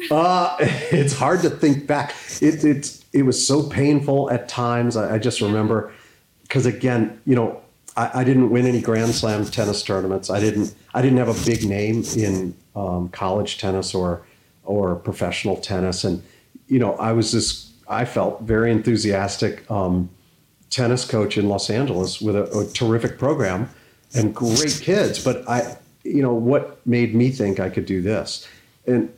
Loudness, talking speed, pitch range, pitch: -21 LUFS, 175 wpm, 100-125 Hz, 115 Hz